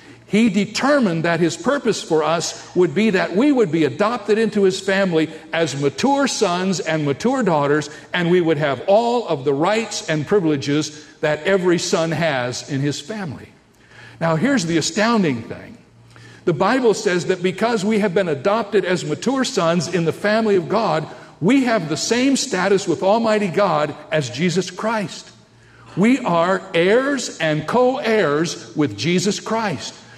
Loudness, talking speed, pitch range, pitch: -19 LUFS, 165 wpm, 155-215 Hz, 185 Hz